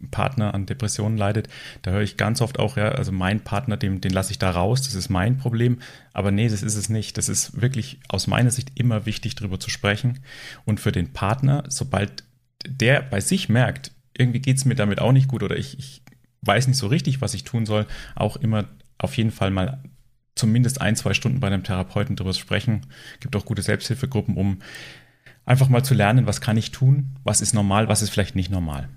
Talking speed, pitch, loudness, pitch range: 220 wpm, 110 Hz, -22 LUFS, 100-125 Hz